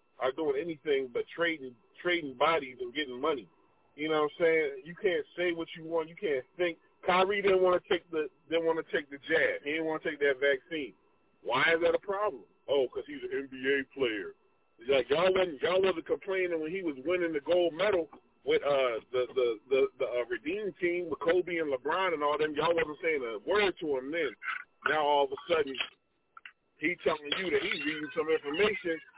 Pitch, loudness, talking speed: 185 Hz, -31 LUFS, 215 wpm